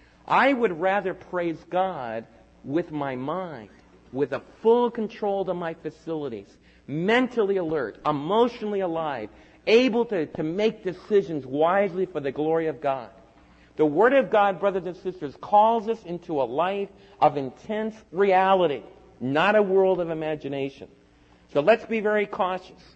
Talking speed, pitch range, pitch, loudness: 145 wpm, 145-205 Hz, 175 Hz, -24 LUFS